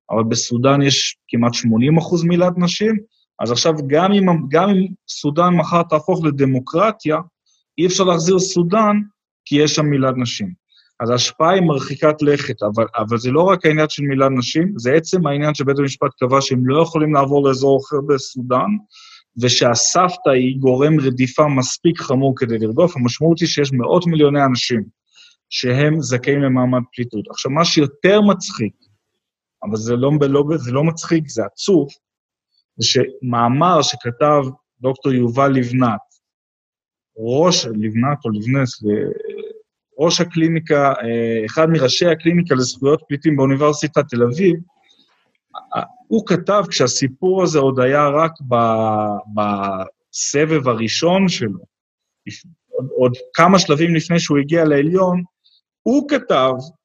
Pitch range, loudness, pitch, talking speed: 125-170 Hz, -16 LUFS, 145 Hz, 130 wpm